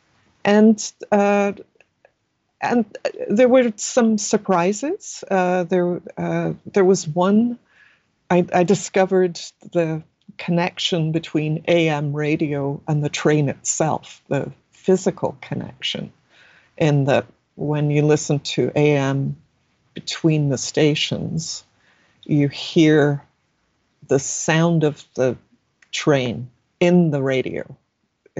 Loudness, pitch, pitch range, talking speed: -20 LUFS, 160 Hz, 145-190 Hz, 100 wpm